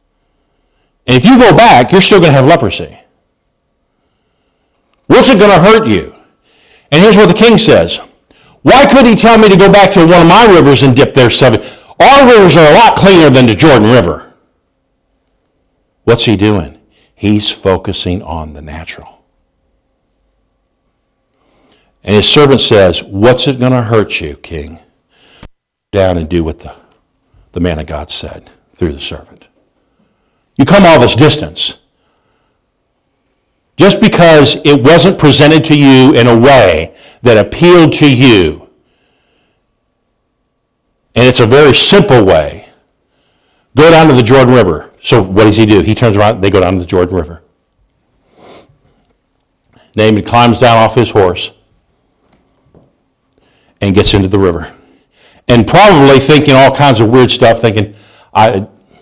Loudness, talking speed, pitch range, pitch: -6 LUFS, 150 wpm, 95-155 Hz, 120 Hz